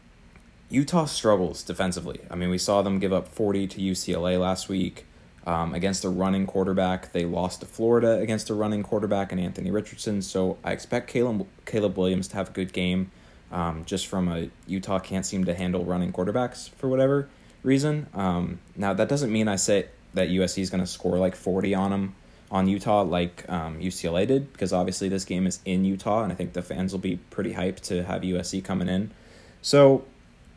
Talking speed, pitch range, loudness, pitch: 200 wpm, 90-105 Hz, -26 LUFS, 95 Hz